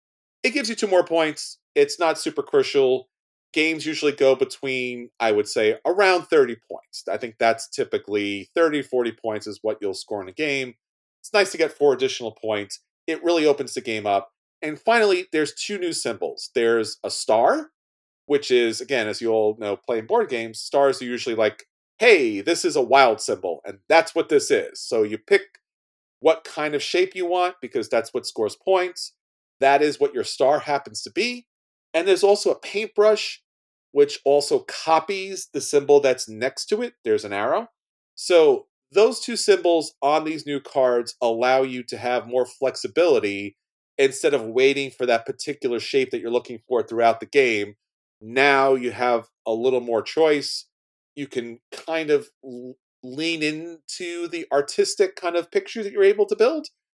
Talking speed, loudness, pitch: 180 wpm, -22 LUFS, 165 Hz